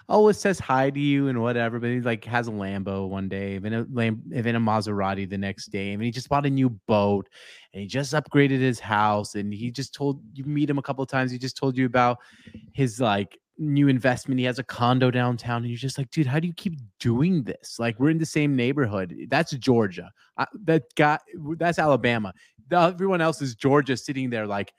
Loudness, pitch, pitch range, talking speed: -25 LUFS, 125 Hz, 110-140 Hz, 230 wpm